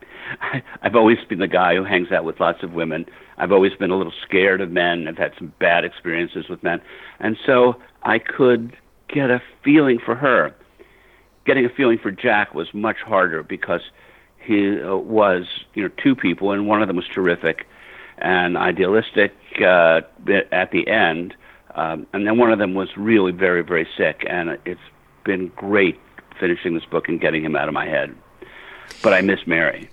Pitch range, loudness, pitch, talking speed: 90-120 Hz, -19 LUFS, 105 Hz, 185 wpm